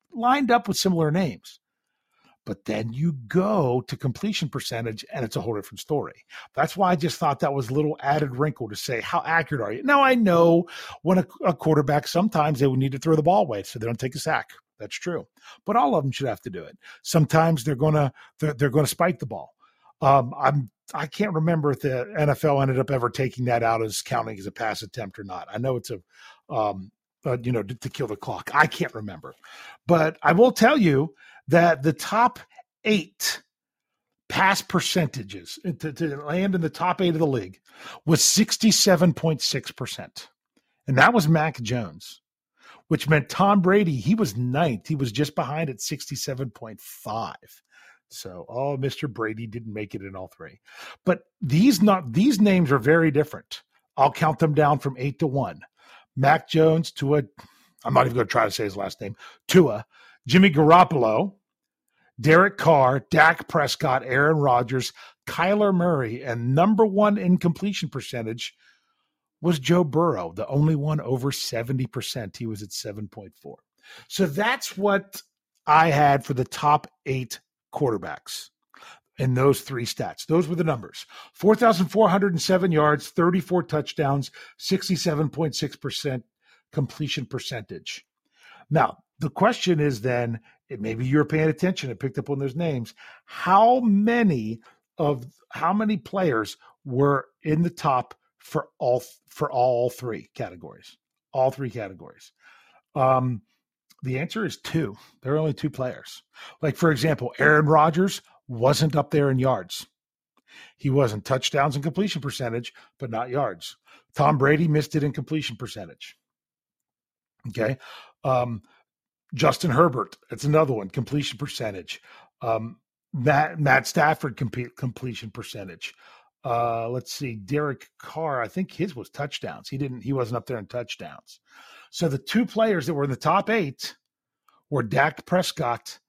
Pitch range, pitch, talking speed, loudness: 130-170 Hz, 150 Hz, 160 wpm, -23 LUFS